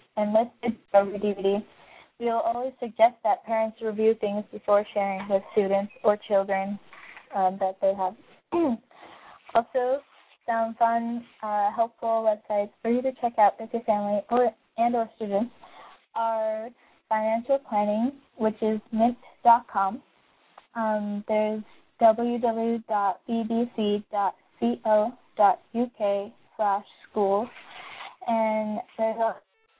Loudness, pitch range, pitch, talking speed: -26 LUFS, 210-235 Hz, 220 Hz, 115 wpm